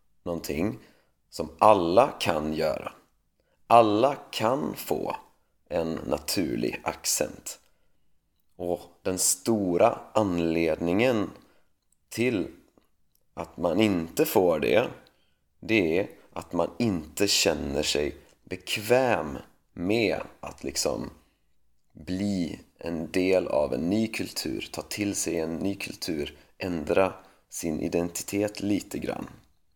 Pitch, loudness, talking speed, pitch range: 90 Hz, -27 LUFS, 100 wpm, 85-100 Hz